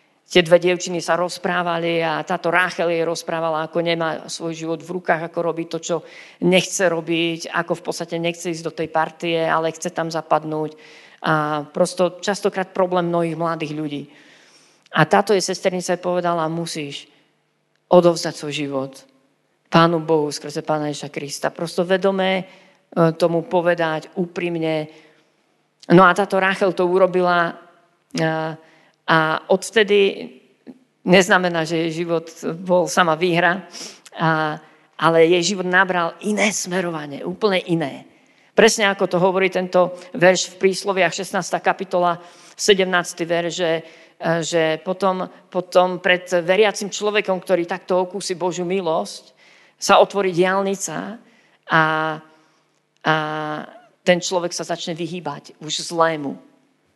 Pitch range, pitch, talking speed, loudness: 160-185 Hz, 170 Hz, 125 wpm, -20 LUFS